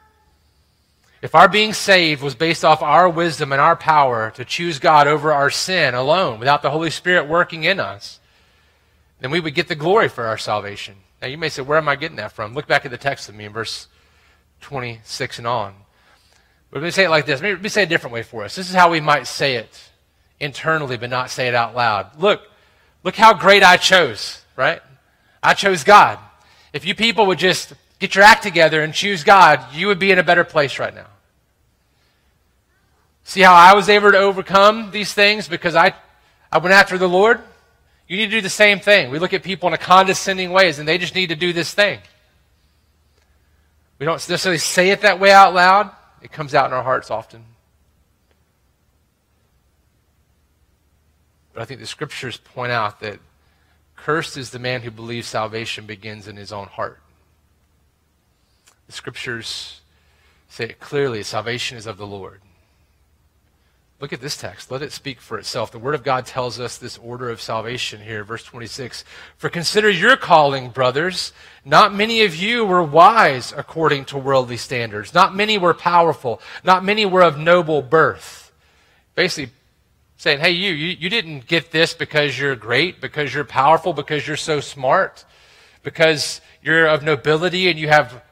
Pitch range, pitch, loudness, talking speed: 110-180 Hz, 145 Hz, -16 LUFS, 190 wpm